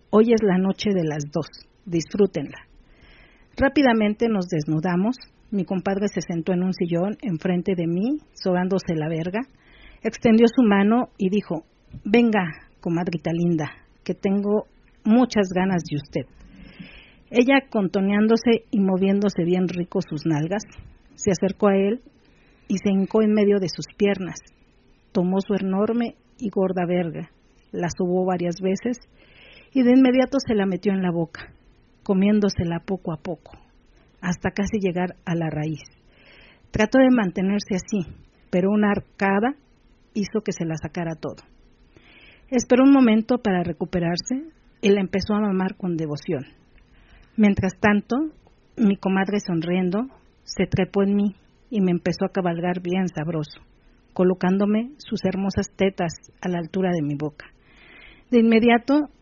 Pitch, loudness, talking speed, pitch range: 195 Hz, -22 LUFS, 140 wpm, 175-215 Hz